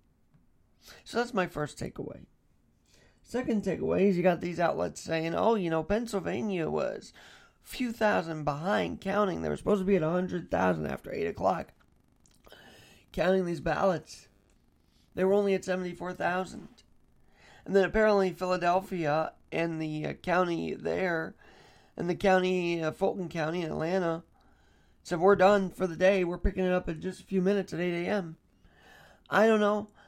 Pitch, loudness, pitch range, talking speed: 185 Hz, -29 LUFS, 165-195 Hz, 160 wpm